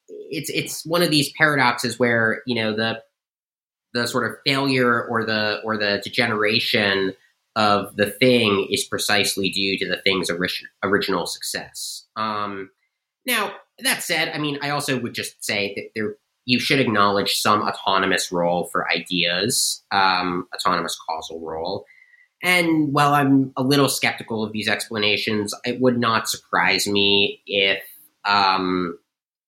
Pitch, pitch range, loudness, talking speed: 110 Hz, 100-130 Hz, -21 LUFS, 145 wpm